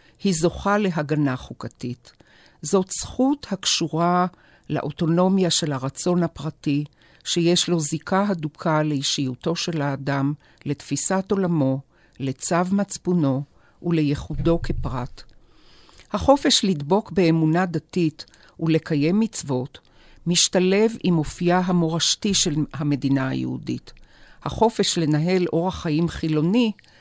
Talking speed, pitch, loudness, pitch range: 95 wpm, 165 Hz, -22 LUFS, 145-185 Hz